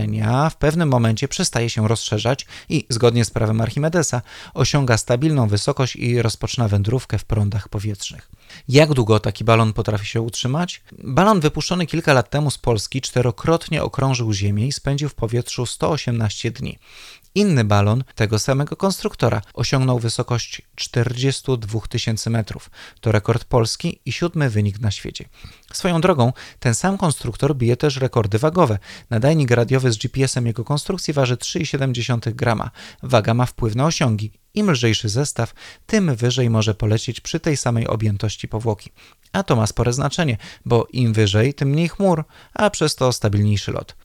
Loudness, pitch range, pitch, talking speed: -20 LUFS, 110-145 Hz, 120 Hz, 155 wpm